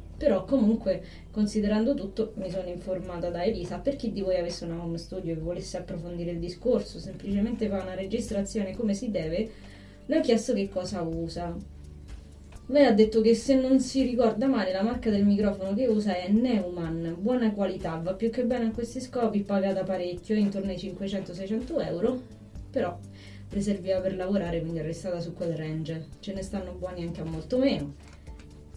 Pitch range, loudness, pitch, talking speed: 175-225 Hz, -28 LUFS, 190 Hz, 180 wpm